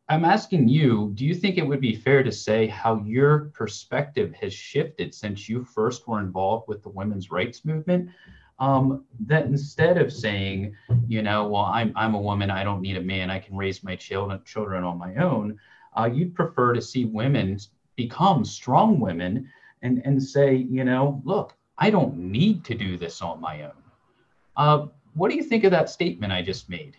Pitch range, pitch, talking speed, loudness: 100-140 Hz, 120 Hz, 195 wpm, -24 LUFS